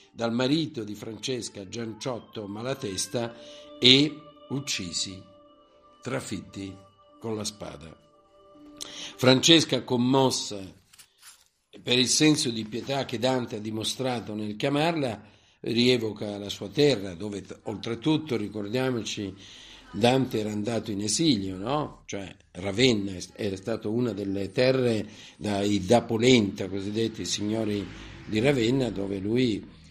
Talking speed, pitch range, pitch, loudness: 110 wpm, 100-130 Hz, 115 Hz, -26 LUFS